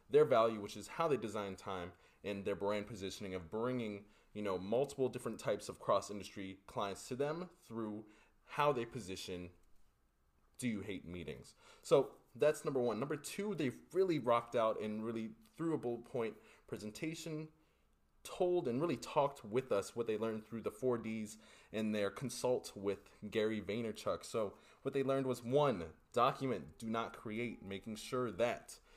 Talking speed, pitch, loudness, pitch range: 170 wpm, 110 Hz, -39 LUFS, 100-125 Hz